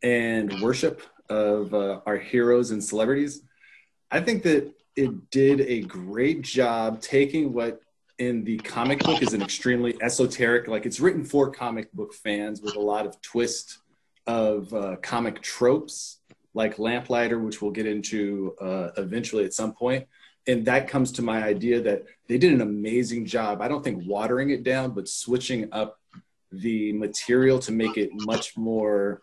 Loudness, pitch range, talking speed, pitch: -25 LUFS, 105-130 Hz, 165 wpm, 115 Hz